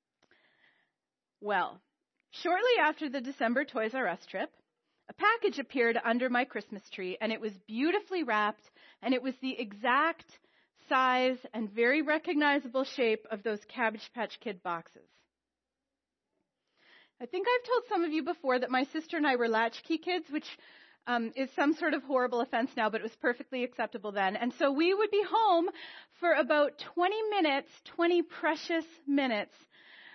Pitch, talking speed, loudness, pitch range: 265 Hz, 160 wpm, -31 LUFS, 230-325 Hz